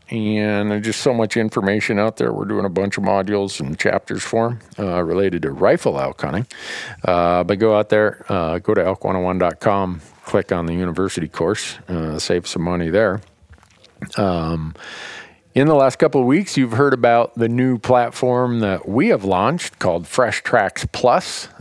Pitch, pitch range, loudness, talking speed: 100 Hz, 90-115 Hz, -19 LUFS, 180 wpm